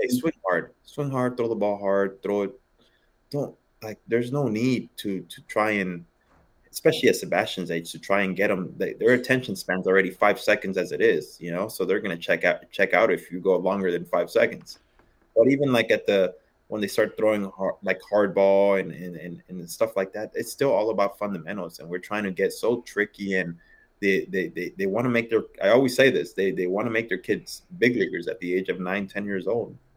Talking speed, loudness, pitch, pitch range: 230 wpm, -25 LUFS, 100 Hz, 95-120 Hz